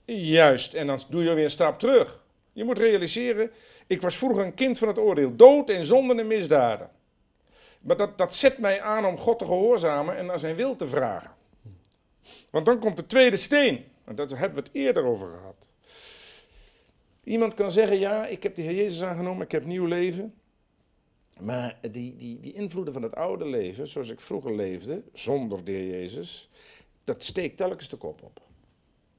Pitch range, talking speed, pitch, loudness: 160-235 Hz, 185 wpm, 200 Hz, -24 LUFS